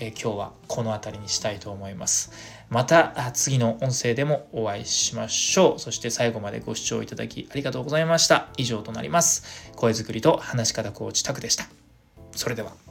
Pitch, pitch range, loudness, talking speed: 115 Hz, 110-130 Hz, -24 LUFS, 390 characters per minute